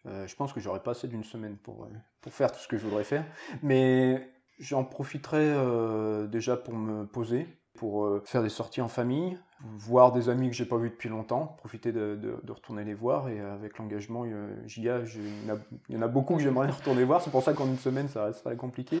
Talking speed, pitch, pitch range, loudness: 235 wpm, 120 Hz, 110-130 Hz, -30 LUFS